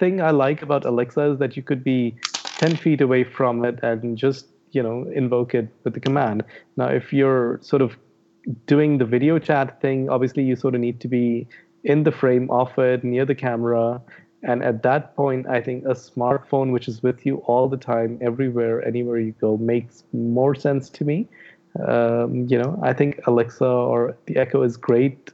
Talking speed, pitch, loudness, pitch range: 200 wpm, 125 Hz, -21 LUFS, 120-140 Hz